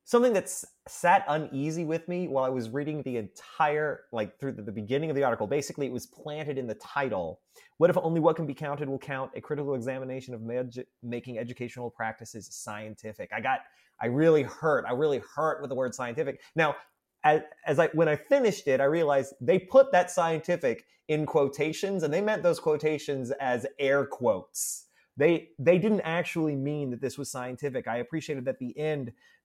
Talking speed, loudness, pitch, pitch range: 195 wpm, -29 LUFS, 145 Hz, 125-160 Hz